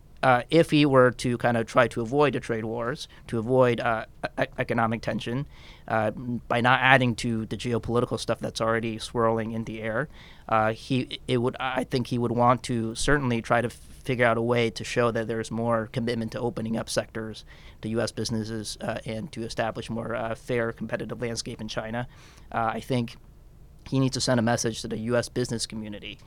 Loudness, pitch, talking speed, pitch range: -26 LUFS, 115 Hz, 205 wpm, 115-125 Hz